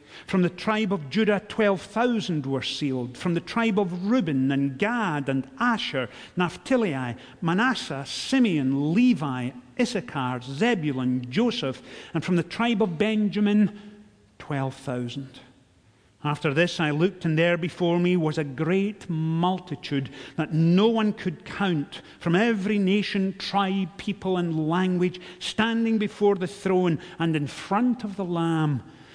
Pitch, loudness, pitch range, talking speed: 175 Hz, -25 LUFS, 145-205 Hz, 135 wpm